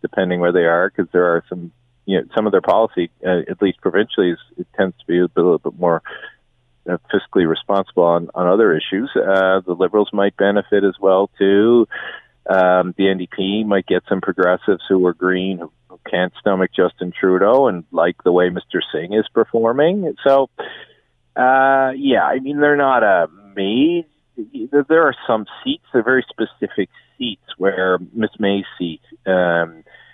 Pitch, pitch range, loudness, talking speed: 100 Hz, 90-125 Hz, -17 LUFS, 175 wpm